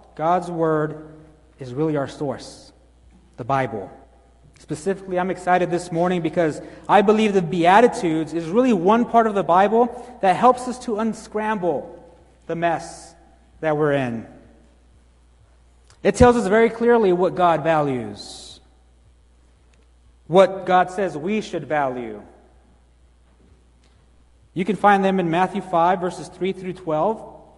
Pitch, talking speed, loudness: 170 Hz, 130 wpm, -20 LUFS